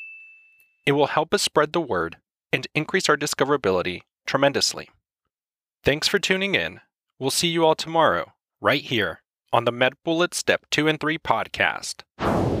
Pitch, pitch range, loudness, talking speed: 155 Hz, 145-180 Hz, -22 LUFS, 150 wpm